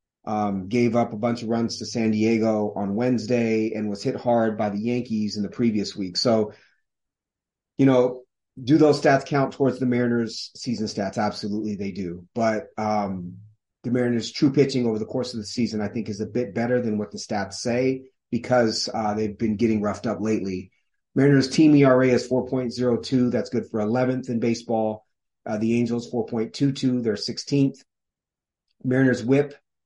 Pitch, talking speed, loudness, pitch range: 115 Hz, 175 wpm, -23 LUFS, 105-125 Hz